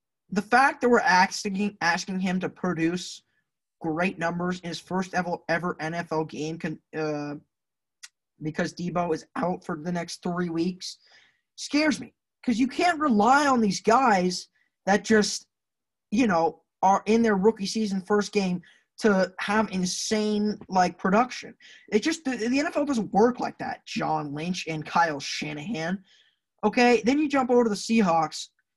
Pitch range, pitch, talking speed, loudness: 170-225 Hz, 190 Hz, 155 wpm, -25 LUFS